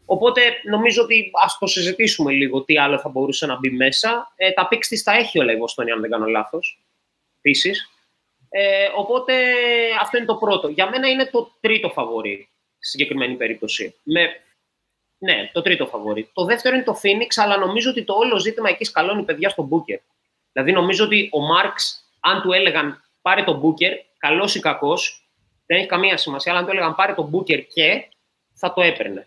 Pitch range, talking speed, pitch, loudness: 150-225 Hz, 190 wpm, 190 Hz, -18 LUFS